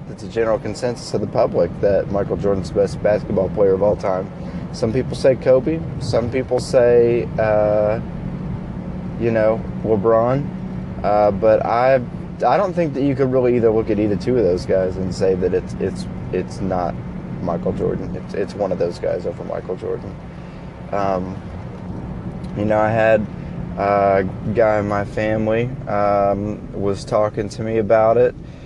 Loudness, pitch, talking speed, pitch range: -19 LUFS, 110 Hz, 170 wpm, 100-125 Hz